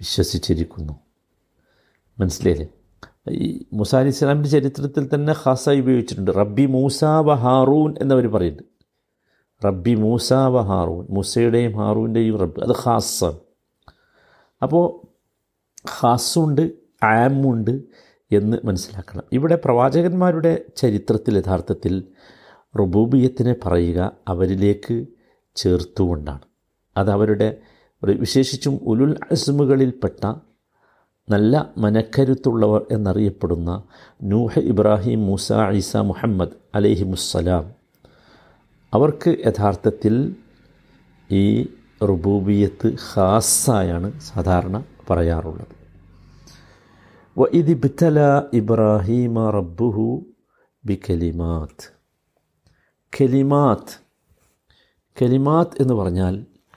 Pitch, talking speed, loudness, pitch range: 110 Hz, 65 wpm, -19 LUFS, 95-130 Hz